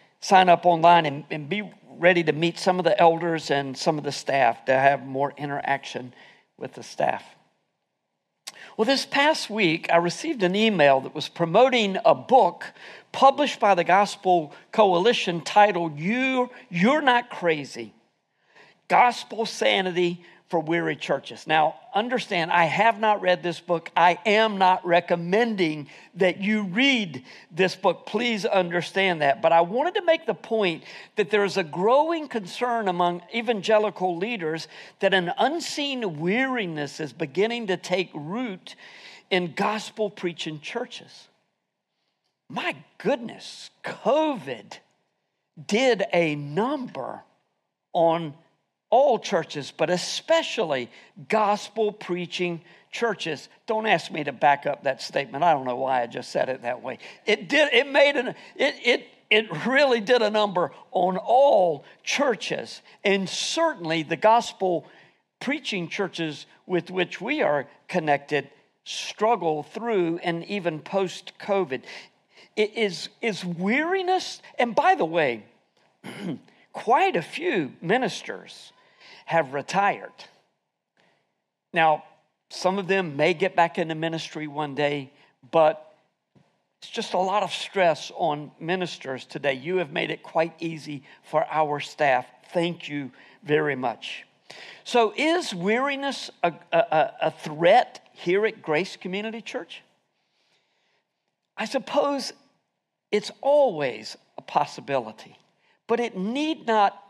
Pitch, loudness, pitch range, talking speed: 185 Hz, -24 LUFS, 160-220 Hz, 130 wpm